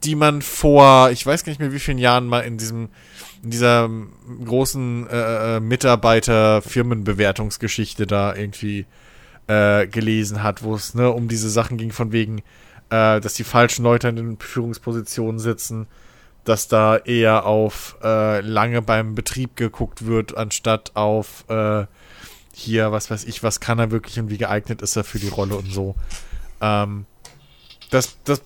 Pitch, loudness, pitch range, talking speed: 110 Hz, -19 LUFS, 105-120 Hz, 160 wpm